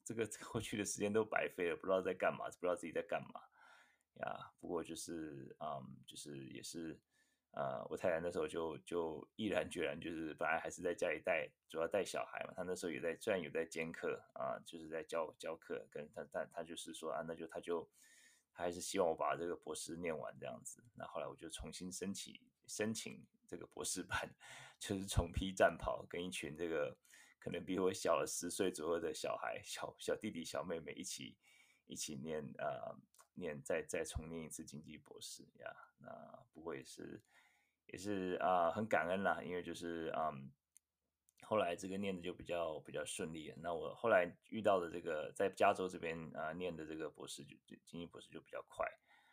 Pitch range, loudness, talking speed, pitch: 80-110 Hz, -43 LUFS, 300 characters per minute, 90 Hz